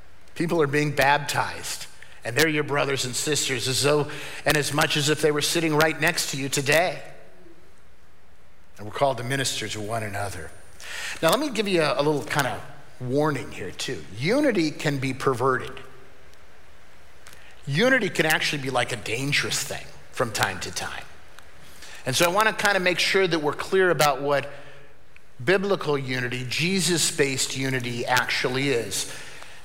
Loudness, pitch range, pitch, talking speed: -23 LUFS, 125-155 Hz, 145 Hz, 170 wpm